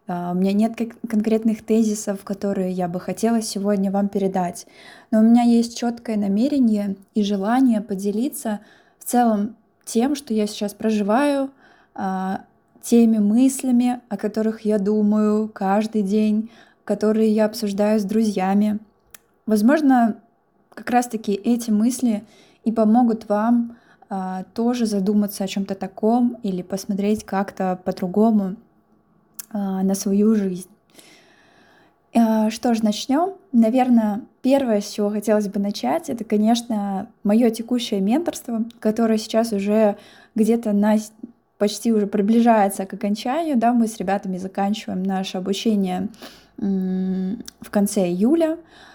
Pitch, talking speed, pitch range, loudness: 215 Hz, 125 wpm, 205-235 Hz, -21 LUFS